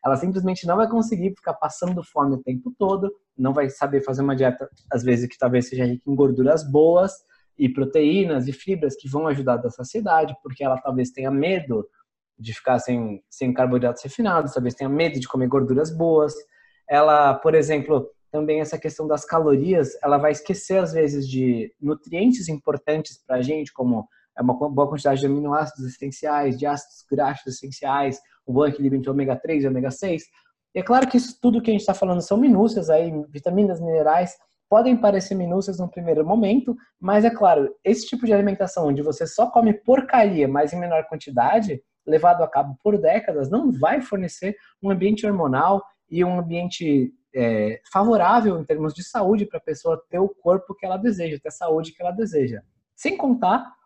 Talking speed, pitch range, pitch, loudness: 190 wpm, 135-195 Hz, 155 Hz, -21 LUFS